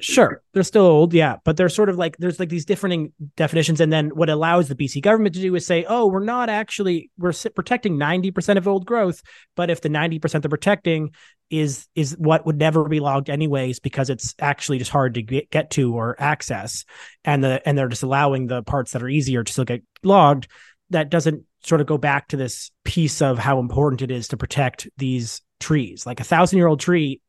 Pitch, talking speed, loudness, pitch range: 155 Hz, 220 wpm, -20 LUFS, 135-175 Hz